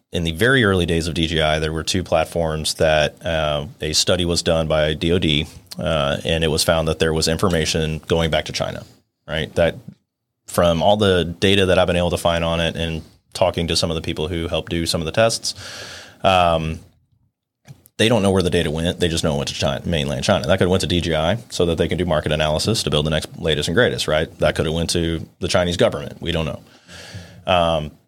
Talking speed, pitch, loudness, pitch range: 235 wpm, 85 Hz, -19 LUFS, 80-90 Hz